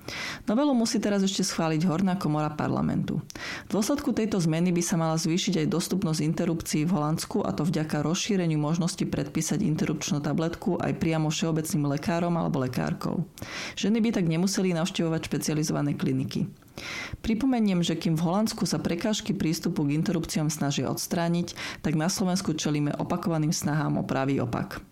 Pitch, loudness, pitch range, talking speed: 170 Hz, -27 LUFS, 160-190 Hz, 150 wpm